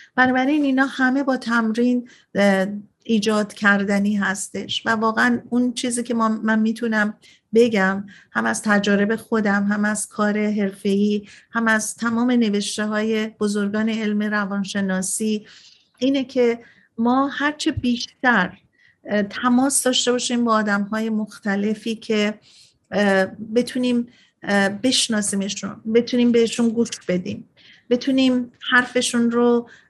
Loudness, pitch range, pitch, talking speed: -20 LUFS, 205-245 Hz, 220 Hz, 110 wpm